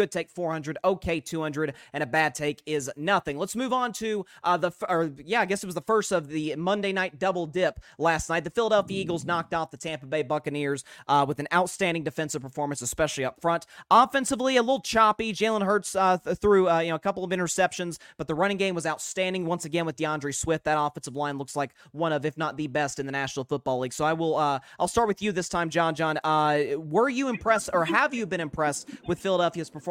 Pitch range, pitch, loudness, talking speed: 150-195 Hz, 165 Hz, -27 LUFS, 235 wpm